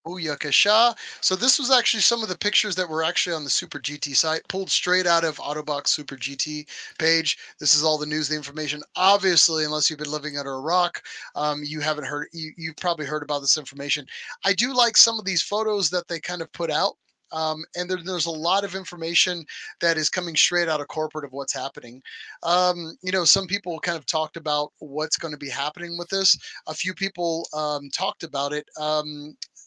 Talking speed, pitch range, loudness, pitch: 210 wpm, 150-180 Hz, -23 LUFS, 160 Hz